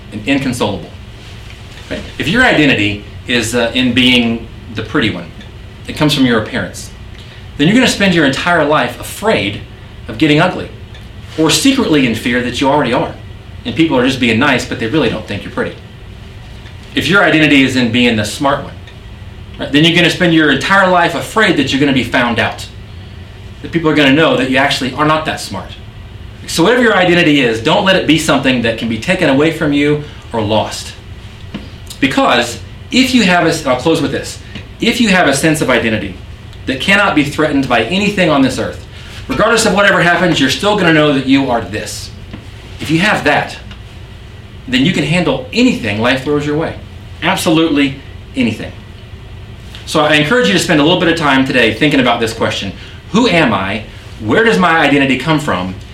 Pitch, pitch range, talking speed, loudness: 120 Hz, 105-155 Hz, 195 wpm, -12 LUFS